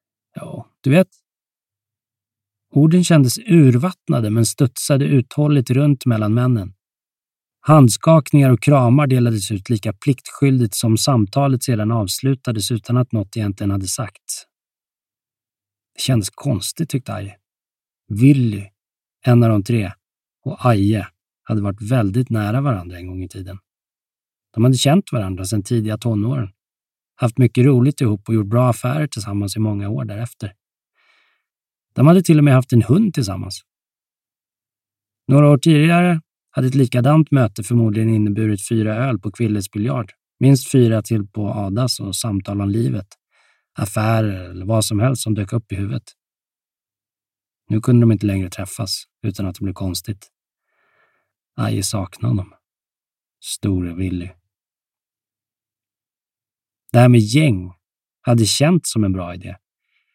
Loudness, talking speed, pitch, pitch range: -17 LUFS, 140 wpm, 110 Hz, 100-130 Hz